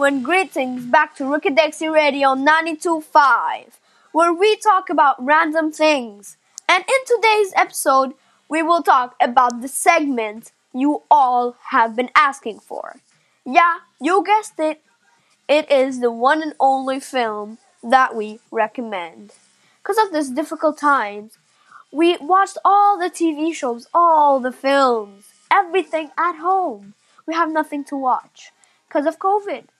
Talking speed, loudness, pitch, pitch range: 135 wpm, -17 LUFS, 305 Hz, 255-340 Hz